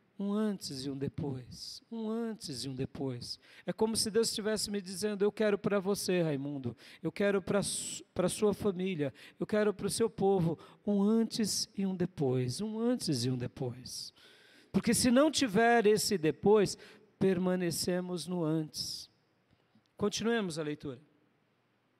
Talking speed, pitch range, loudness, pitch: 155 wpm, 150-215 Hz, -32 LUFS, 195 Hz